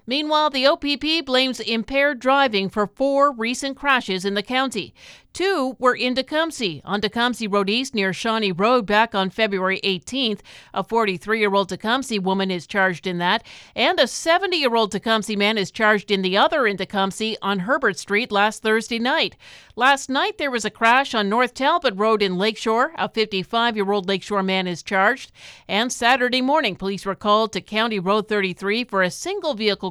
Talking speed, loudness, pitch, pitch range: 175 wpm, -20 LUFS, 220 Hz, 200-255 Hz